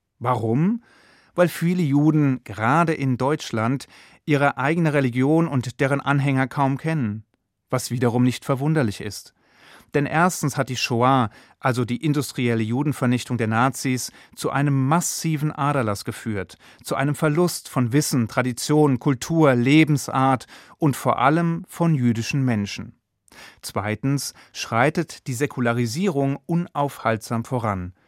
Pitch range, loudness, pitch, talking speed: 120-150 Hz, -22 LUFS, 135 Hz, 120 wpm